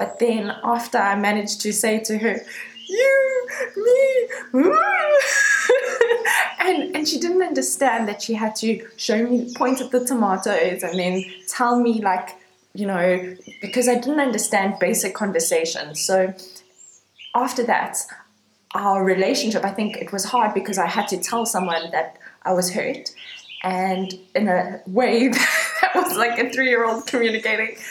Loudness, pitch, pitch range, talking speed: -20 LUFS, 225 Hz, 190-265 Hz, 155 wpm